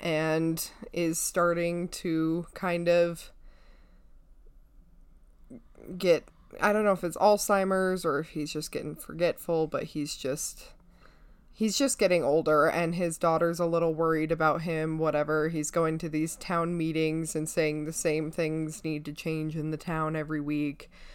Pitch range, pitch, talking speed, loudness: 155-175 Hz, 160 Hz, 155 wpm, -28 LUFS